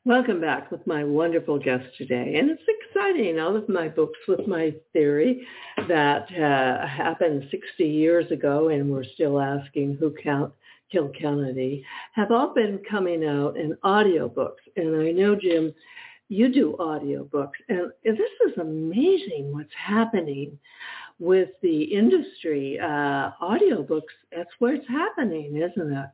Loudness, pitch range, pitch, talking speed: -24 LUFS, 145-220 Hz, 165 Hz, 140 wpm